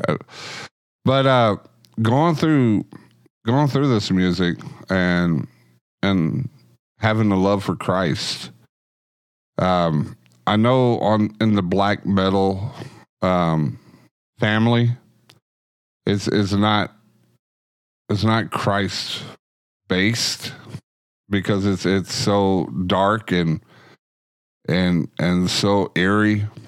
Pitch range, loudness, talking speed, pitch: 90-110 Hz, -20 LUFS, 95 wpm, 100 Hz